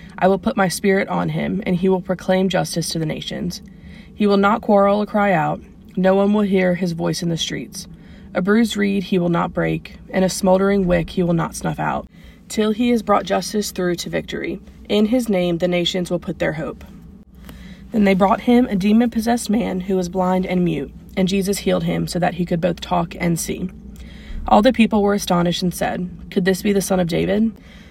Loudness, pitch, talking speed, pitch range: -19 LUFS, 190 Hz, 220 wpm, 180-205 Hz